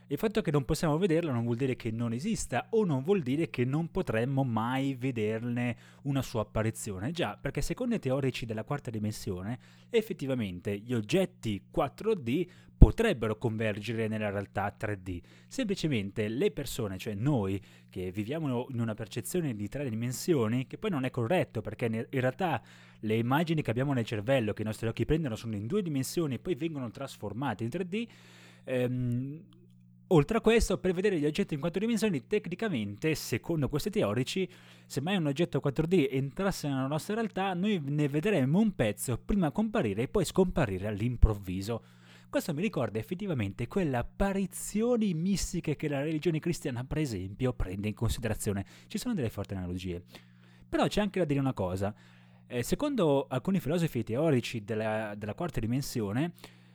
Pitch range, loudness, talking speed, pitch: 110-165 Hz, -31 LUFS, 165 wpm, 130 Hz